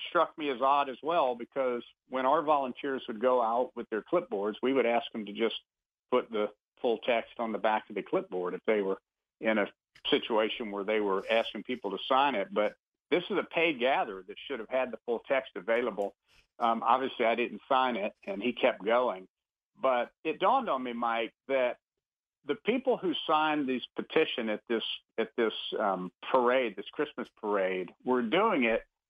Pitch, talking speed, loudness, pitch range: 120 Hz, 195 wpm, -31 LUFS, 105-135 Hz